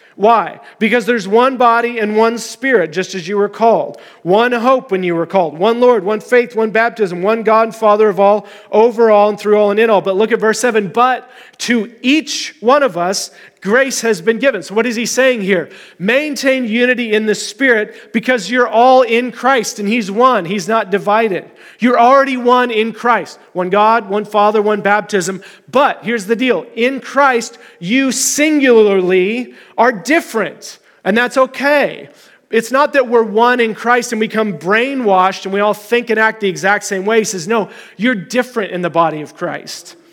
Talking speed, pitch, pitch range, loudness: 195 wpm, 225 Hz, 205-245 Hz, -13 LUFS